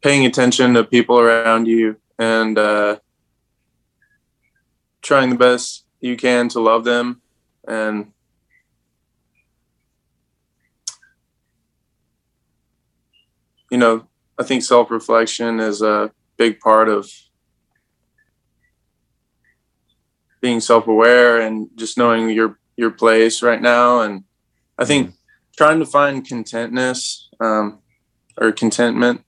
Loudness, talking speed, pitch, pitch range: -16 LUFS, 100 wpm, 115 Hz, 110-125 Hz